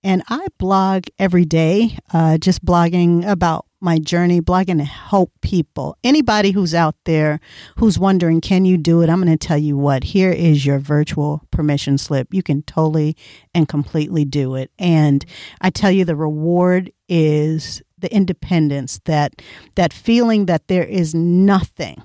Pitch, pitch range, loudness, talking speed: 170 Hz, 150-185 Hz, -17 LUFS, 165 wpm